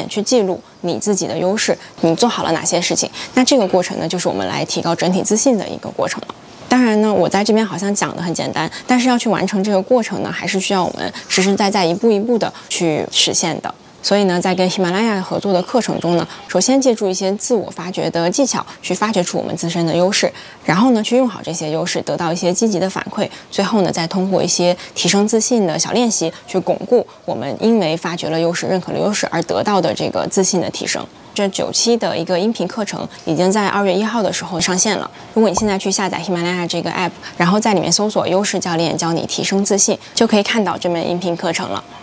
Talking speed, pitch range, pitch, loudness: 365 characters per minute, 175-210 Hz, 190 Hz, -17 LUFS